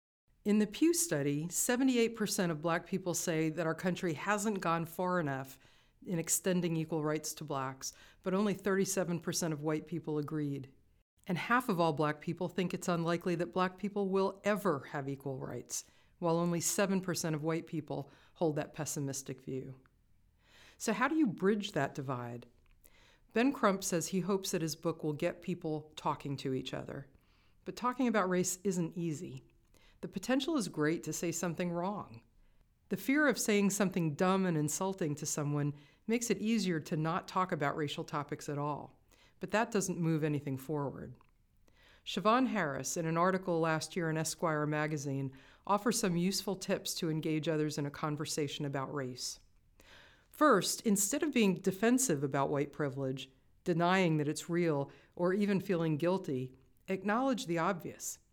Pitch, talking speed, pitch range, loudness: 170 Hz, 165 wpm, 150-195 Hz, -34 LUFS